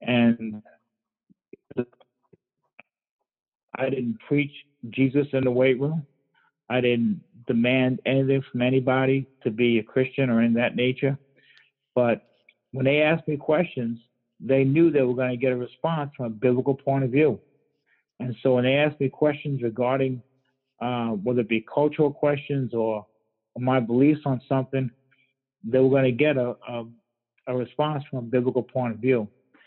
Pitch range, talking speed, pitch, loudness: 125-140 Hz, 160 wpm, 130 Hz, -24 LUFS